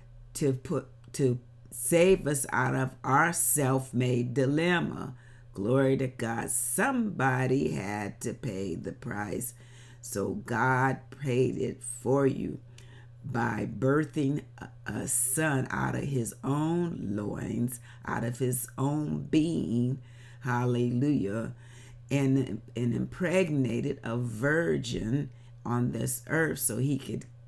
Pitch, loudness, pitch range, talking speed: 125 Hz, -29 LUFS, 120-135 Hz, 115 wpm